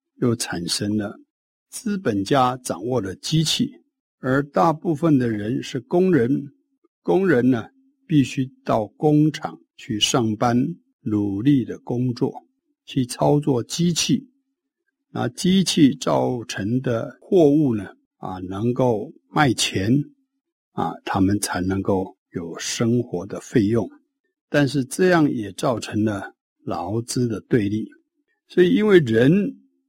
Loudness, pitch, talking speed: -21 LUFS, 140 Hz, 175 characters per minute